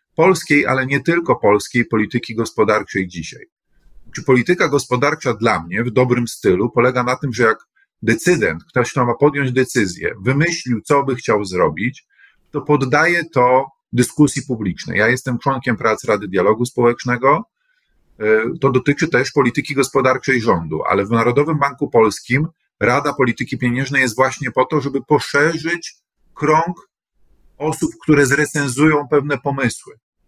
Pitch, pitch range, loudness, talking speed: 130 Hz, 120-145 Hz, -17 LUFS, 135 wpm